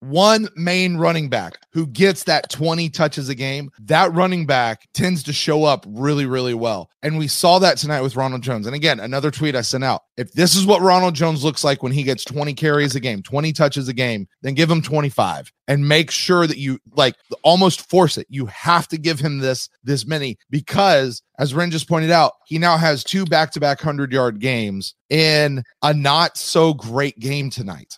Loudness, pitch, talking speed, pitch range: -18 LUFS, 150 Hz, 210 wpm, 135-165 Hz